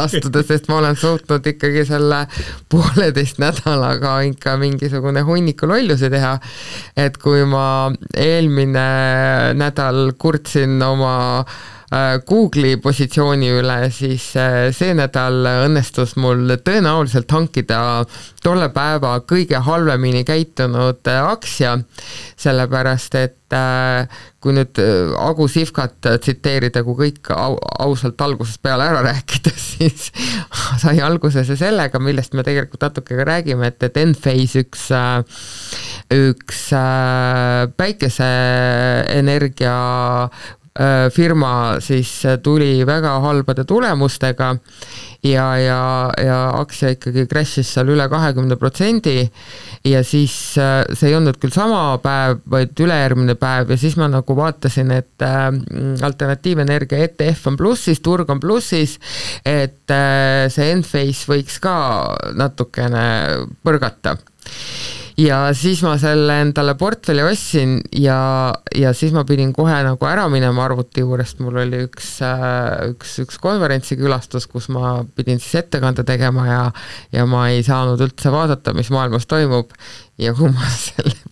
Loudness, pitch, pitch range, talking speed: -16 LUFS, 135 Hz, 125-150 Hz, 115 wpm